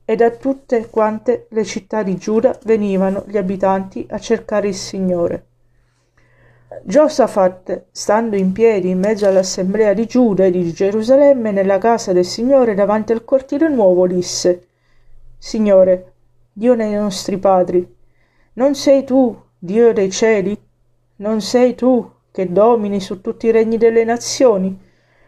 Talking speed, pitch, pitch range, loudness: 140 wpm, 205 Hz, 185-230 Hz, -15 LUFS